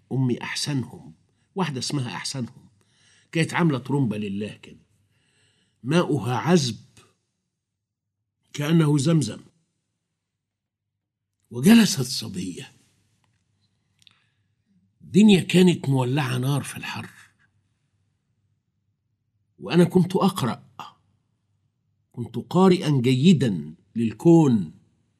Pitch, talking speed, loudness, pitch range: 120 Hz, 70 wpm, -22 LUFS, 105-150 Hz